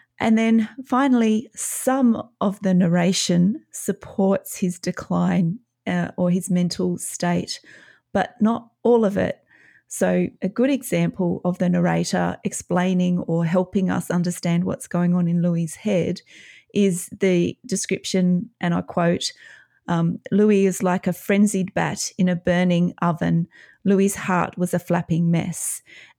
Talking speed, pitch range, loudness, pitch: 135 wpm, 175-205 Hz, -22 LUFS, 185 Hz